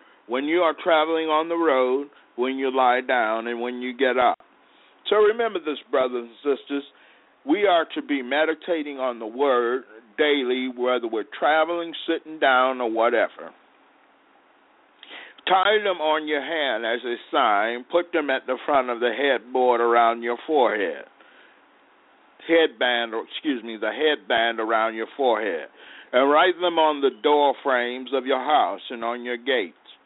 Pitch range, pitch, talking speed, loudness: 120-155 Hz, 130 Hz, 160 wpm, -23 LUFS